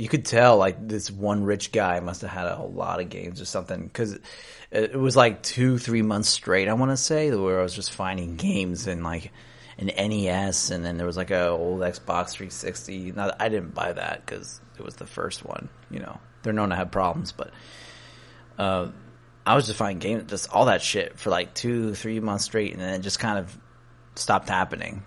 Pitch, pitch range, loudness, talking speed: 100 Hz, 95-110 Hz, -25 LUFS, 220 wpm